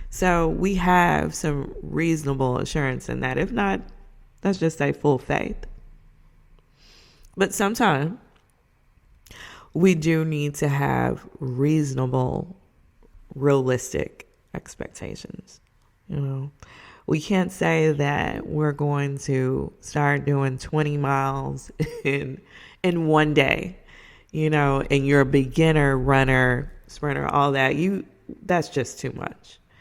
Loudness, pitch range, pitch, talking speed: -23 LUFS, 135-160 Hz, 145 Hz, 115 wpm